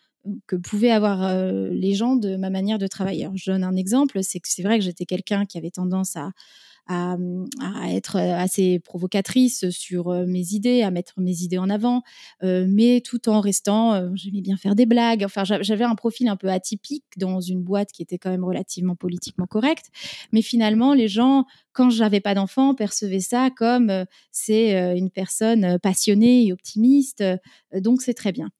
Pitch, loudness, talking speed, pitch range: 200 Hz, -21 LUFS, 180 wpm, 185-230 Hz